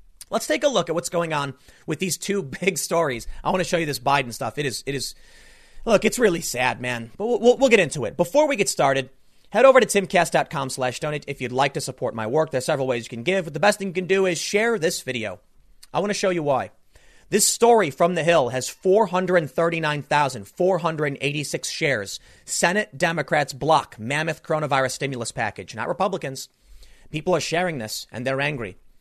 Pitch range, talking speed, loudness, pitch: 135-185 Hz, 210 wpm, -22 LUFS, 160 Hz